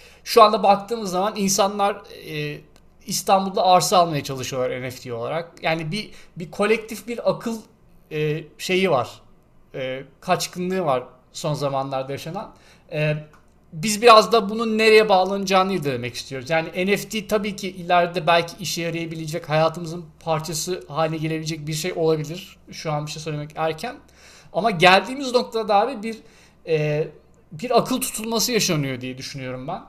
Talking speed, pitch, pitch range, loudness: 145 wpm, 175 Hz, 155-205 Hz, -21 LUFS